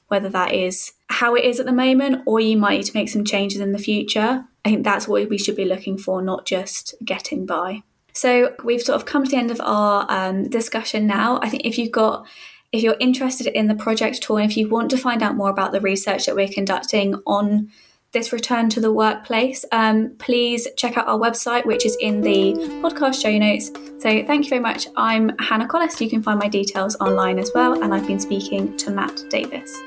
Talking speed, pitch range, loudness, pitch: 225 wpm, 200-245 Hz, -19 LUFS, 220 Hz